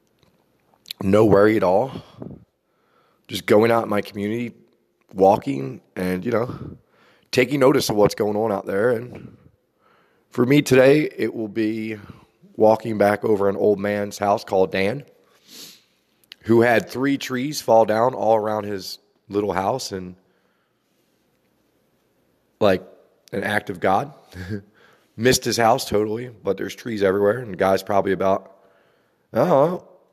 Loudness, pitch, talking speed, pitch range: -20 LUFS, 105 Hz, 140 wpm, 100-120 Hz